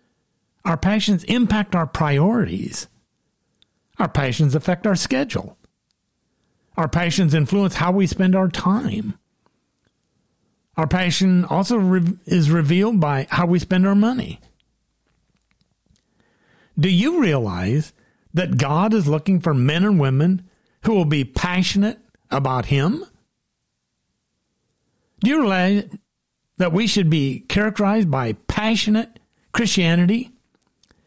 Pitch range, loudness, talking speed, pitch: 160-205 Hz, -19 LUFS, 110 wpm, 185 Hz